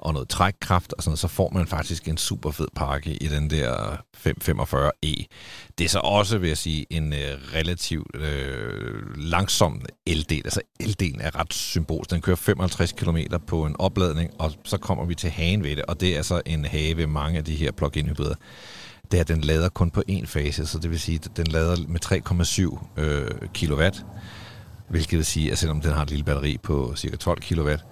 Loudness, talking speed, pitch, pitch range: -25 LUFS, 210 wpm, 80 Hz, 75-90 Hz